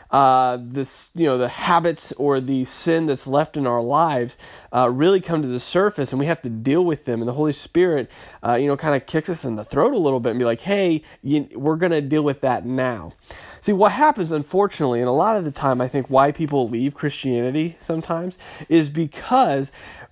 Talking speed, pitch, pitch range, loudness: 225 wpm, 140 Hz, 125-165 Hz, -20 LUFS